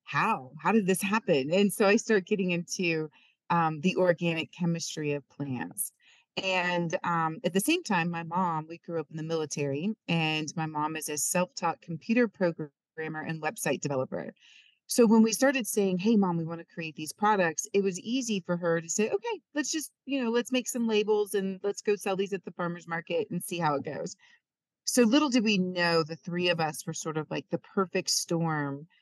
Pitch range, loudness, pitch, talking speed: 160-210 Hz, -29 LUFS, 175 Hz, 210 wpm